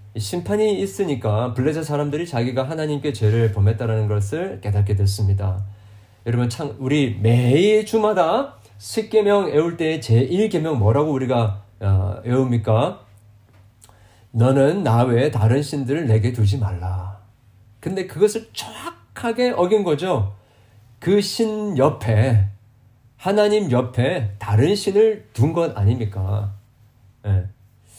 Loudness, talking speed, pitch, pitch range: -20 LUFS, 250 characters per minute, 115 Hz, 105-160 Hz